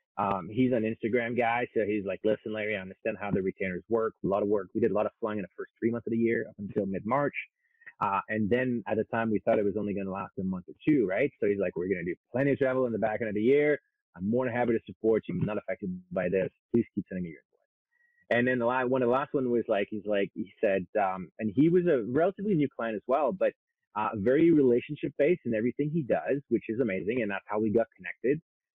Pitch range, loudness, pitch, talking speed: 105-140 Hz, -29 LUFS, 115 Hz, 275 wpm